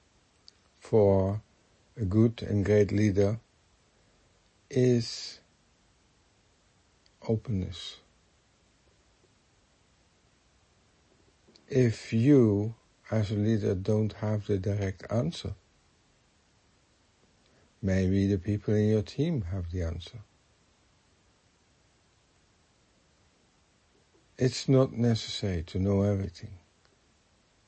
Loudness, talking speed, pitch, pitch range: -28 LUFS, 70 wpm, 100 Hz, 95-110 Hz